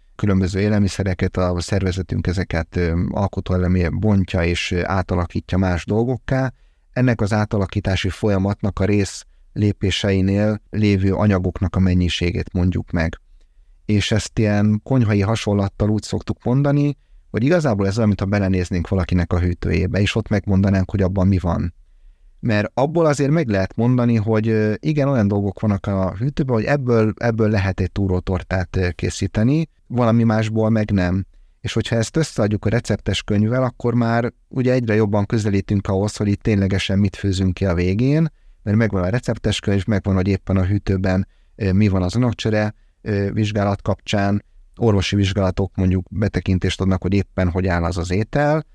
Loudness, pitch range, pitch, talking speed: -20 LUFS, 95-110 Hz, 100 Hz, 150 wpm